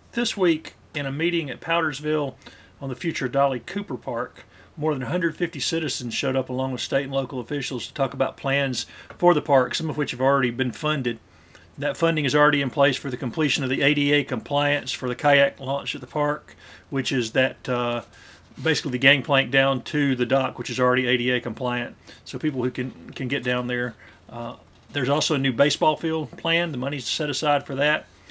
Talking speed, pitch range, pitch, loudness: 210 wpm, 125-150 Hz, 135 Hz, -23 LUFS